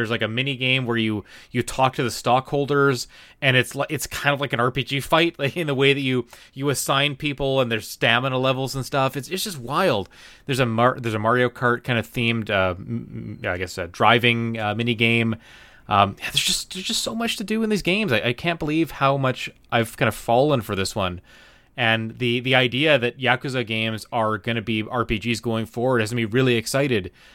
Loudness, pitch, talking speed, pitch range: -22 LUFS, 125 Hz, 225 wpm, 115-140 Hz